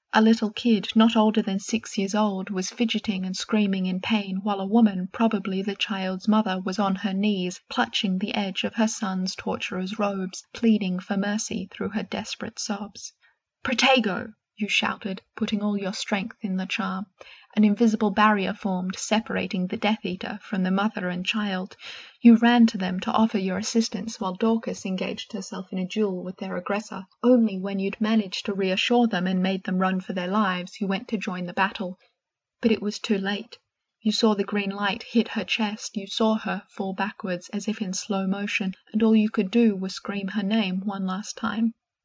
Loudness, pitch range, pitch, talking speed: -25 LUFS, 190-220 Hz, 205 Hz, 195 wpm